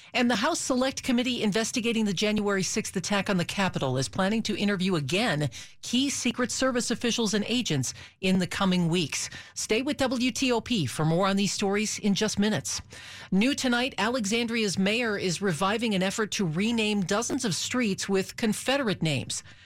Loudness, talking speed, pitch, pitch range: -27 LUFS, 170 wpm, 205 Hz, 185-235 Hz